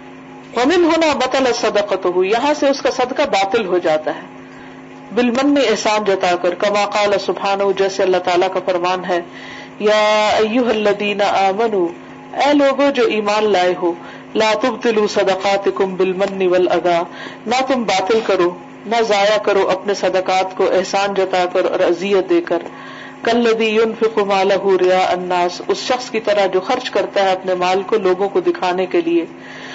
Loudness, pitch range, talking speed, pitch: -16 LUFS, 185-235 Hz, 165 wpm, 200 Hz